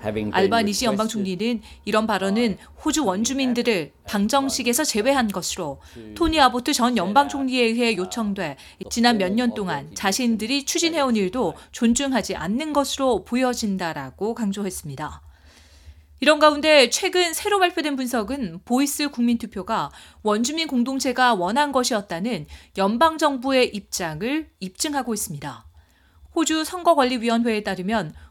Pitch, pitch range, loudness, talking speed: 235 Hz, 195-270 Hz, -22 LUFS, 320 characters per minute